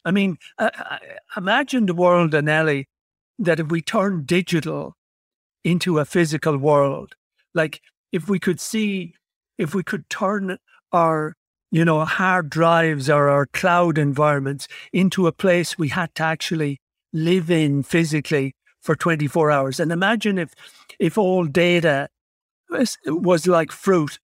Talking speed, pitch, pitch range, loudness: 140 wpm, 170 Hz, 155-185 Hz, -20 LUFS